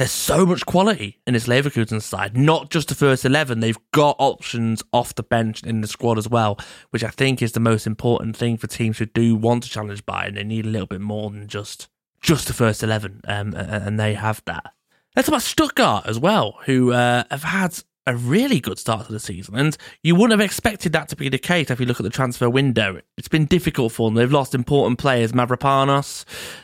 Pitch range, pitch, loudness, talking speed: 110-140 Hz, 120 Hz, -20 LUFS, 230 wpm